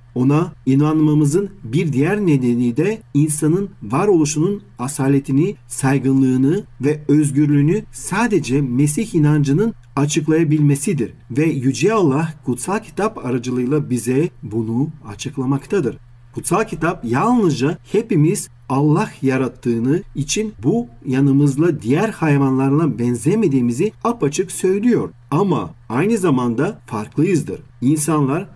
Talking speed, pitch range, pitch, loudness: 90 wpm, 130-170 Hz, 145 Hz, -18 LUFS